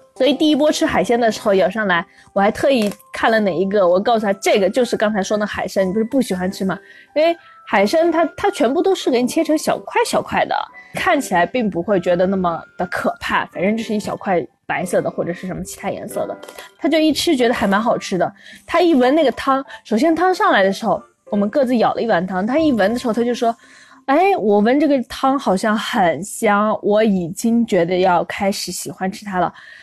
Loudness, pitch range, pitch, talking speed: -18 LUFS, 195-295 Hz, 225 Hz, 330 characters per minute